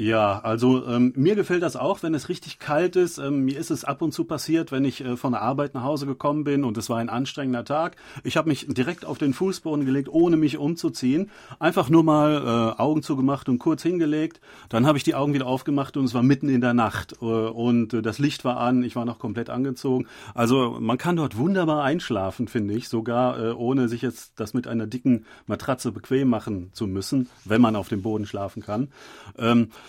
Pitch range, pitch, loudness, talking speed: 120-150 Hz, 130 Hz, -24 LUFS, 225 wpm